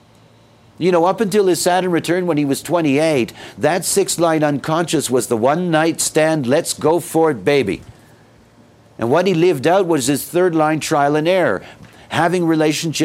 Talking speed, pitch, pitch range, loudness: 165 wpm, 155 Hz, 140-175 Hz, -16 LUFS